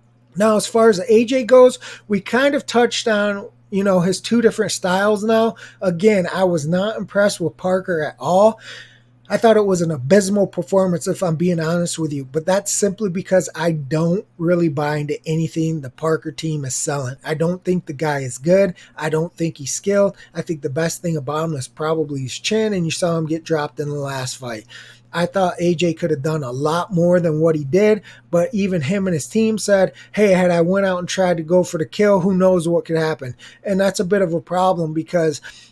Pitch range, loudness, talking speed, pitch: 160-195 Hz, -18 LUFS, 225 wpm, 175 Hz